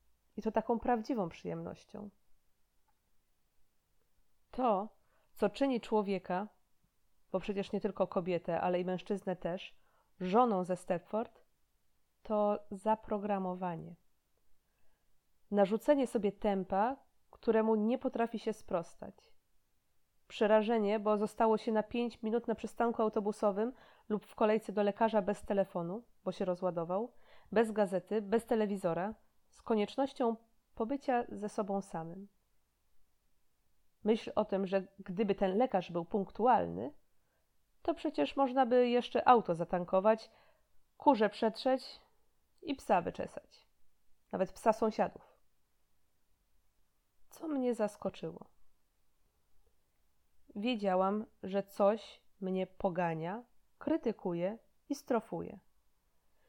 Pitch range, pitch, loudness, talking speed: 190-230 Hz, 210 Hz, -34 LUFS, 100 wpm